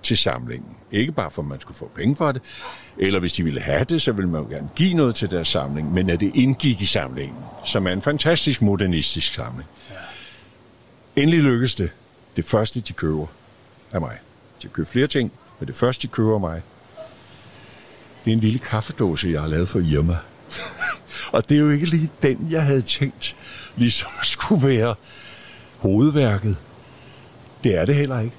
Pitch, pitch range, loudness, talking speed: 120 Hz, 90-135 Hz, -21 LUFS, 190 wpm